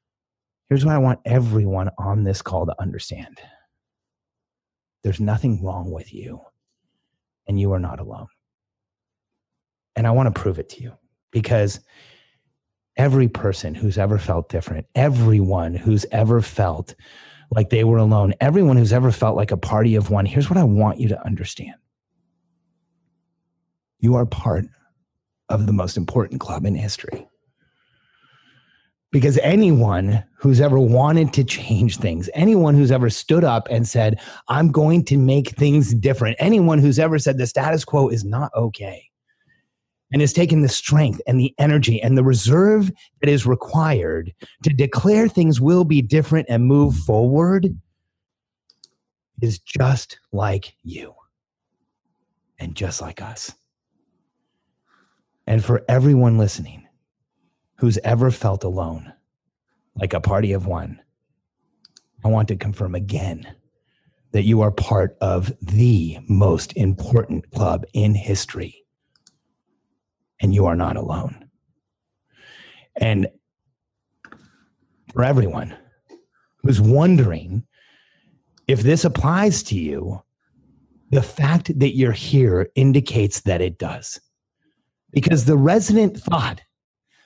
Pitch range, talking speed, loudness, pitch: 100-140 Hz, 130 wpm, -18 LUFS, 115 Hz